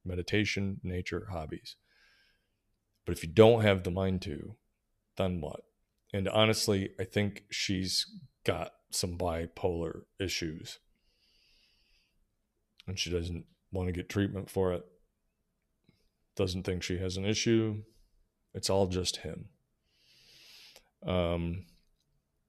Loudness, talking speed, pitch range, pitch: -32 LUFS, 110 wpm, 90-105 Hz, 95 Hz